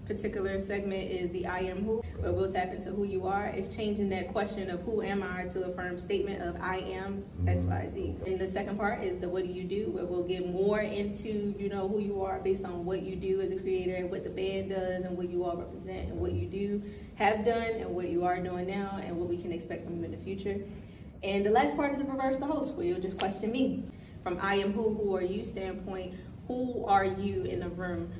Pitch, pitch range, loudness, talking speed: 190 Hz, 180-205 Hz, -33 LUFS, 255 wpm